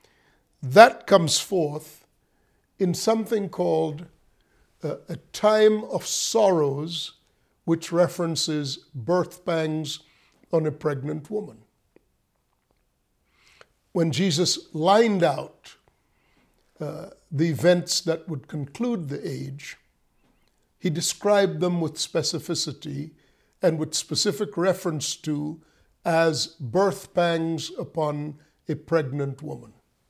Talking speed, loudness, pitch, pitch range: 95 wpm, -24 LUFS, 165 Hz, 150-180 Hz